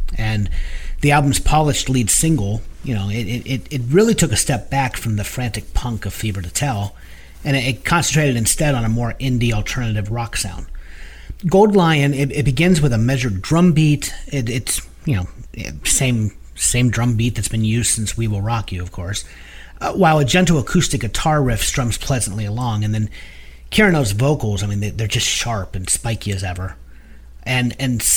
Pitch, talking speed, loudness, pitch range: 115 Hz, 195 wpm, -18 LUFS, 100-140 Hz